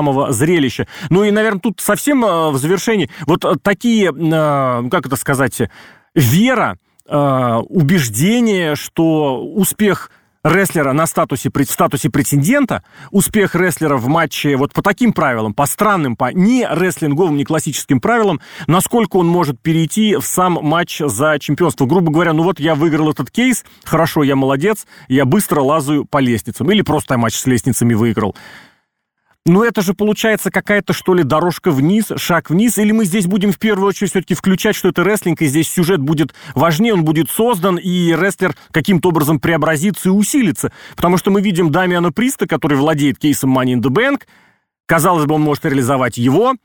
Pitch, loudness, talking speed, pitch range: 165 Hz, -14 LUFS, 165 wpm, 145-195 Hz